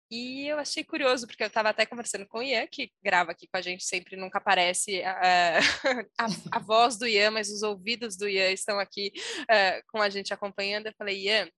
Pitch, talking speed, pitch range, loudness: 210 Hz, 225 wpm, 190-230 Hz, -27 LUFS